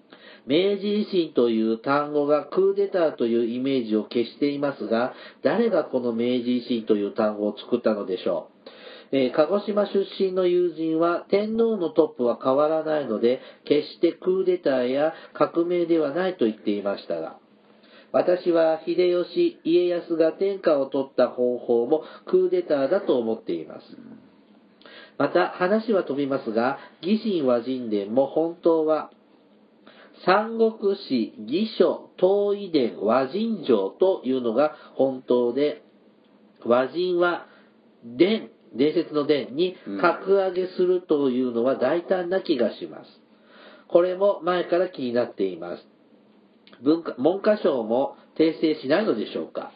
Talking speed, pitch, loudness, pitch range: 270 characters per minute, 160 Hz, -24 LUFS, 130-190 Hz